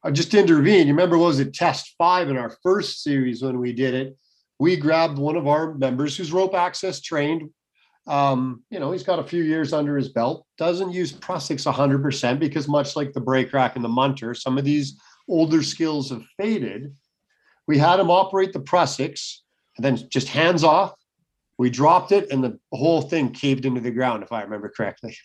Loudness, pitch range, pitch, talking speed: -21 LUFS, 130-170 Hz, 145 Hz, 200 wpm